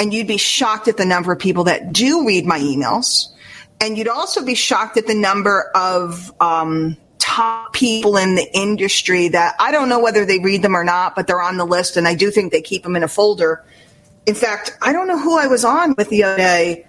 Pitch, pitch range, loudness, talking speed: 195 Hz, 175-225 Hz, -16 LUFS, 240 wpm